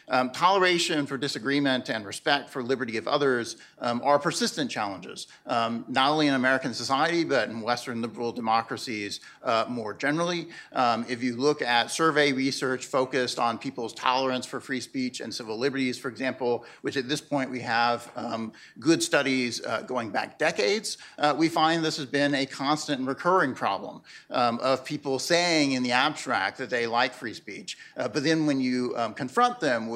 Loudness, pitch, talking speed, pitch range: -26 LUFS, 130 Hz, 185 wpm, 120-150 Hz